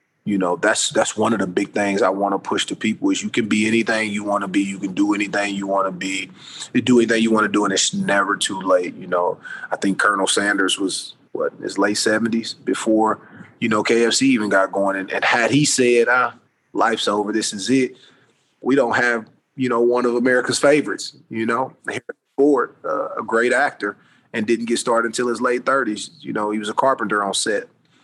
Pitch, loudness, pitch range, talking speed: 115 Hz, -19 LUFS, 100-125 Hz, 225 wpm